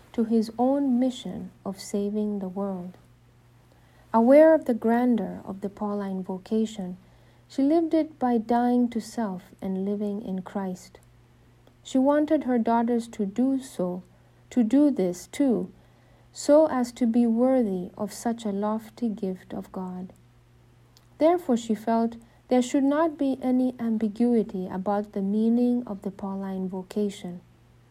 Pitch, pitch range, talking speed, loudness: 215 Hz, 190-245 Hz, 140 wpm, -25 LUFS